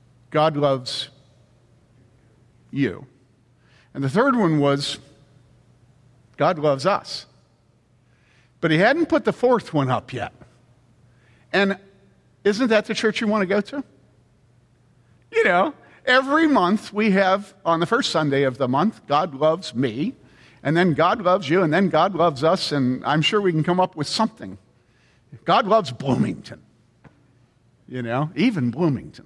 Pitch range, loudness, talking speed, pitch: 125-195 Hz, -21 LUFS, 150 wpm, 145 Hz